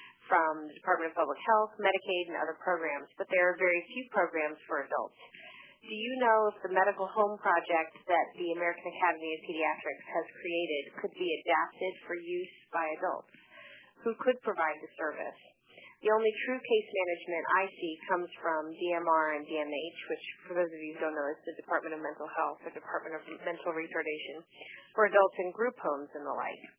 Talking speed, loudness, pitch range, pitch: 190 wpm, -32 LUFS, 160-195 Hz, 175 Hz